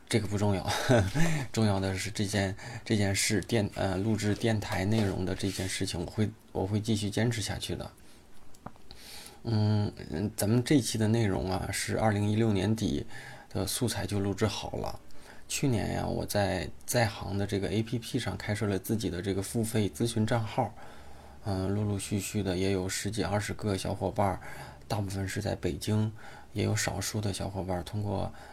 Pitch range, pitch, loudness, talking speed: 95-110 Hz, 105 Hz, -31 LUFS, 265 characters per minute